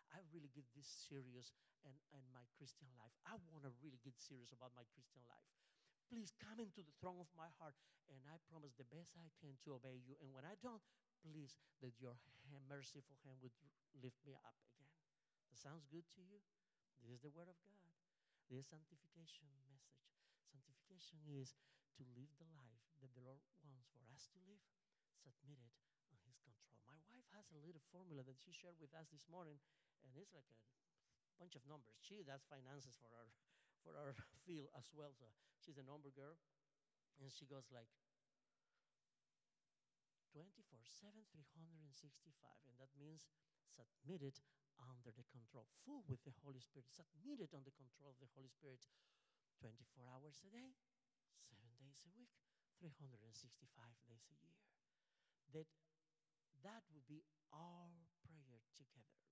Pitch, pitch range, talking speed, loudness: 145 Hz, 130-160 Hz, 170 wpm, -63 LUFS